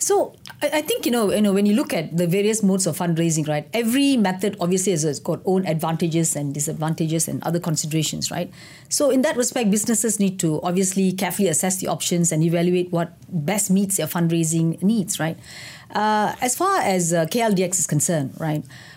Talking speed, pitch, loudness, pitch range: 190 wpm, 180 Hz, -21 LUFS, 165-205 Hz